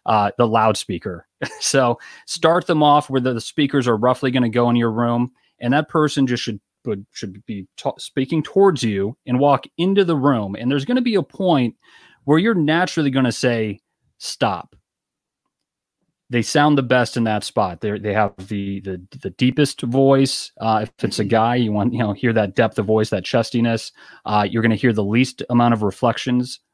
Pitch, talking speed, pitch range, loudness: 120 Hz, 200 wpm, 110-145 Hz, -19 LUFS